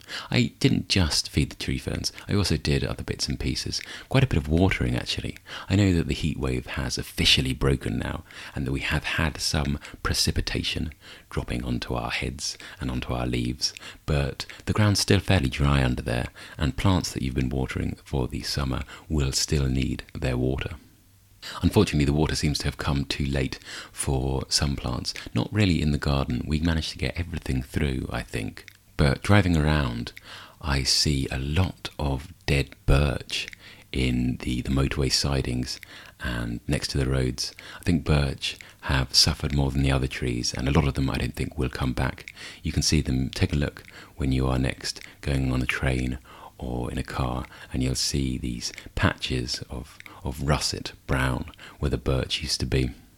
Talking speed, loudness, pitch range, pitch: 190 wpm, -26 LUFS, 65-85 Hz, 70 Hz